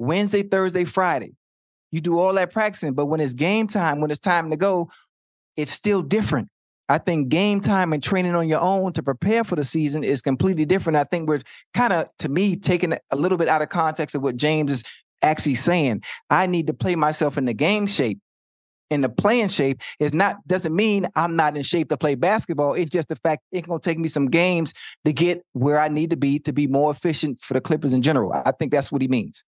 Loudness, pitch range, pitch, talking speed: -22 LUFS, 145-180 Hz, 160 Hz, 230 wpm